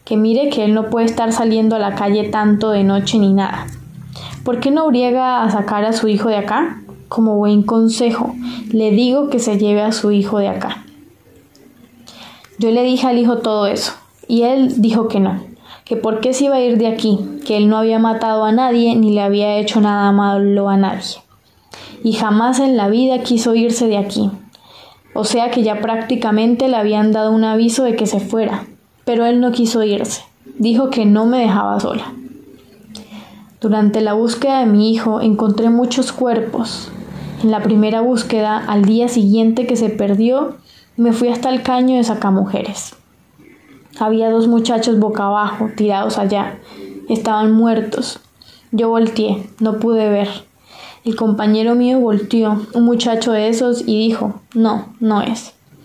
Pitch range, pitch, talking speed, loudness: 210-235 Hz, 220 Hz, 175 wpm, -15 LUFS